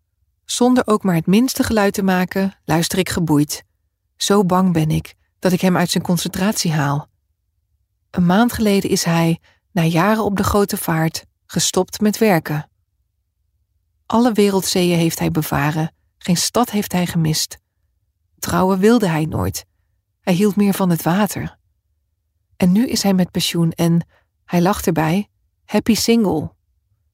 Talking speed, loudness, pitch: 150 wpm, -18 LUFS, 170 Hz